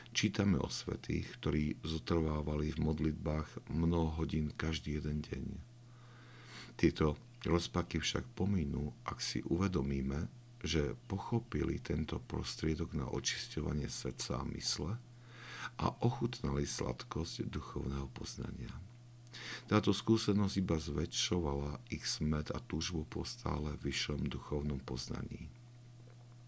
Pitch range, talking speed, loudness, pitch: 75-110 Hz, 105 wpm, -38 LUFS, 80 Hz